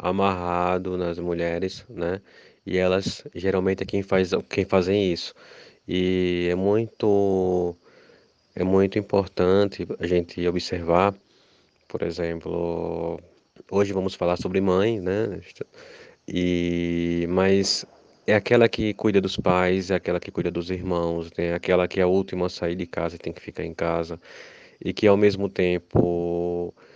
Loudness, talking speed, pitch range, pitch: -24 LUFS, 145 wpm, 85-100 Hz, 90 Hz